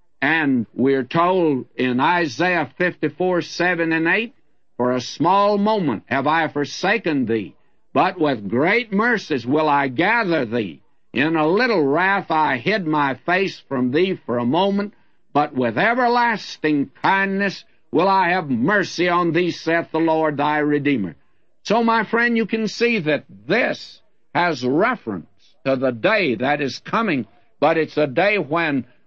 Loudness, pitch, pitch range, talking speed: -19 LUFS, 170 Hz, 145-200 Hz, 155 wpm